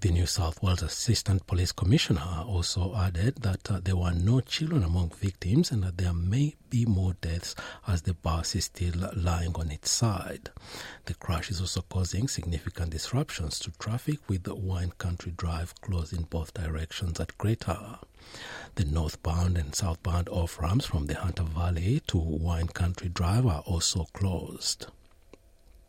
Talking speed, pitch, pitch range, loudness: 160 wpm, 90 Hz, 85-100 Hz, -30 LUFS